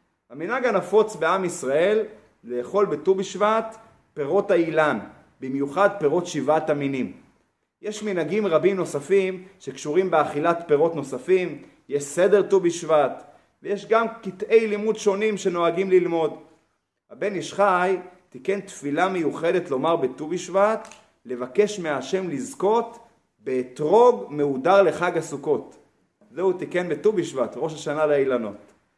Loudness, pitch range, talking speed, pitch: -23 LUFS, 155-205 Hz, 115 wpm, 180 Hz